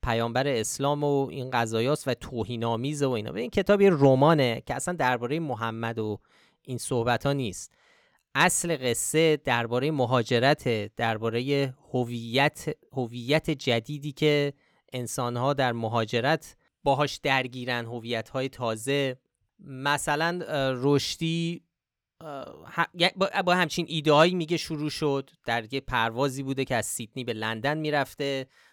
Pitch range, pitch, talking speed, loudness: 120-150 Hz, 135 Hz, 120 wpm, -27 LUFS